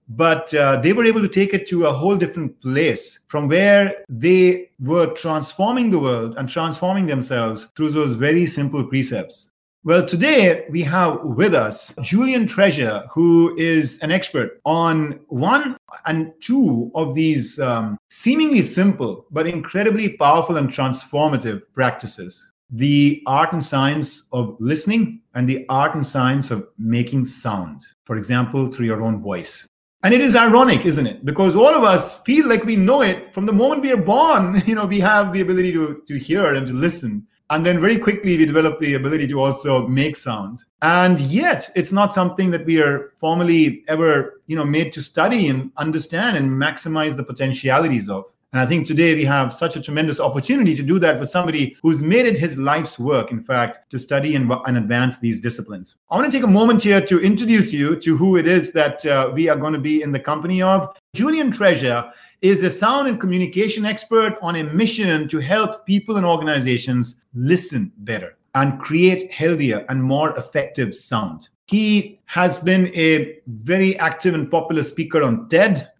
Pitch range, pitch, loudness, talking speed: 135-190 Hz, 160 Hz, -18 LUFS, 185 wpm